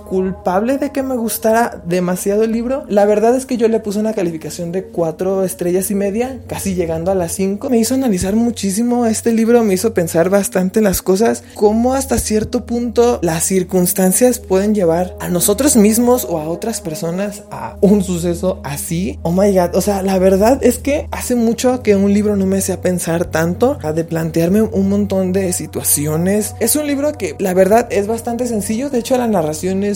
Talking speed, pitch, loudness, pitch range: 200 wpm, 200 Hz, -15 LUFS, 185-230 Hz